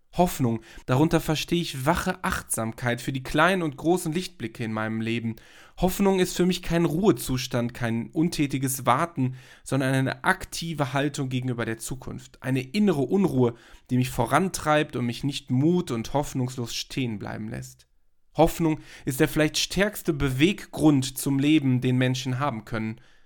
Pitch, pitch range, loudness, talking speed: 135 Hz, 120-160 Hz, -25 LUFS, 150 wpm